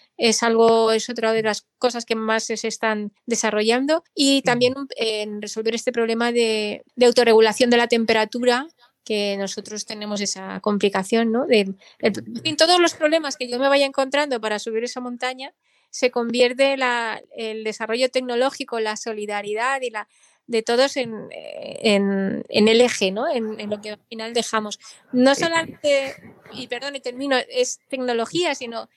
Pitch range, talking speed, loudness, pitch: 220-260 Hz, 165 wpm, -21 LUFS, 235 Hz